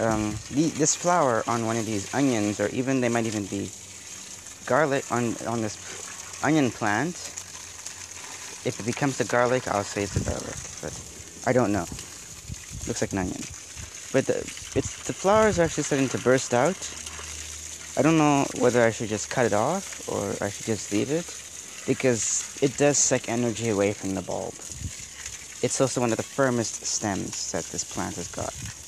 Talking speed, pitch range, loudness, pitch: 180 wpm, 100-130 Hz, -26 LUFS, 115 Hz